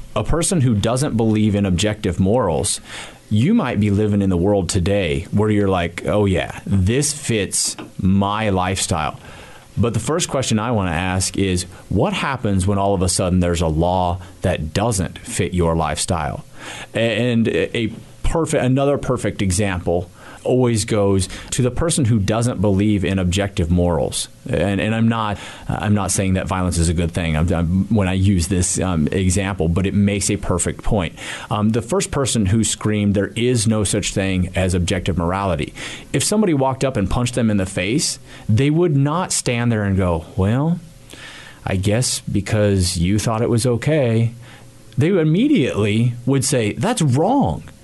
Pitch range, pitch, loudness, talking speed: 95-120 Hz, 105 Hz, -19 LUFS, 175 wpm